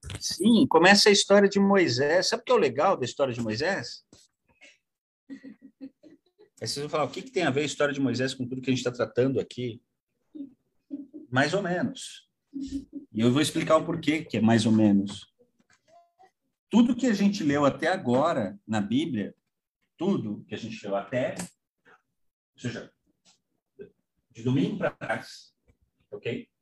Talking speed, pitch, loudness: 165 wpm, 165 Hz, -25 LUFS